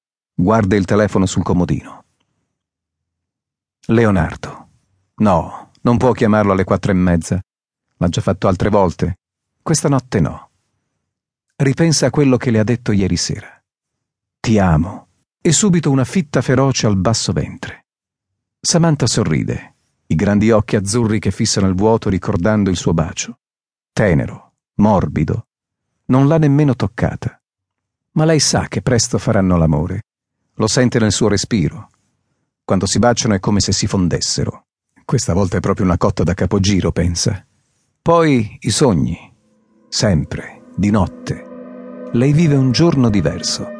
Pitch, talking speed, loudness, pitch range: 110 Hz, 140 wpm, -16 LUFS, 95-130 Hz